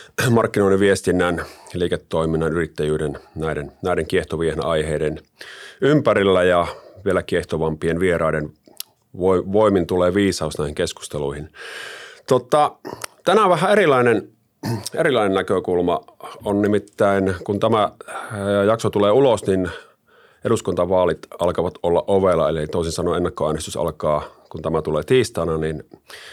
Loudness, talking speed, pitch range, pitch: -20 LUFS, 105 wpm, 80-100 Hz, 90 Hz